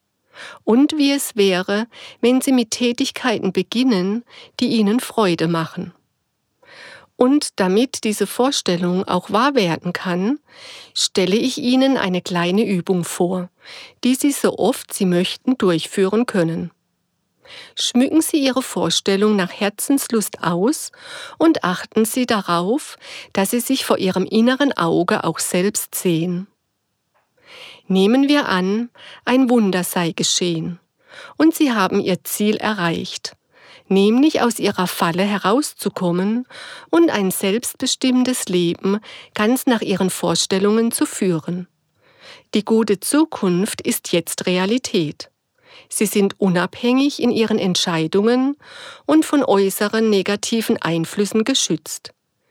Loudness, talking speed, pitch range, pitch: -18 LUFS, 120 wpm, 185-255 Hz, 215 Hz